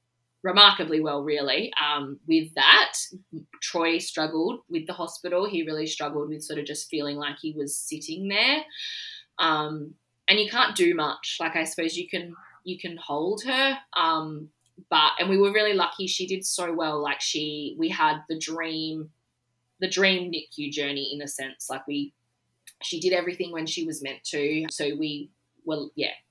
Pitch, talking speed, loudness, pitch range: 160 Hz, 175 wpm, -25 LUFS, 145-185 Hz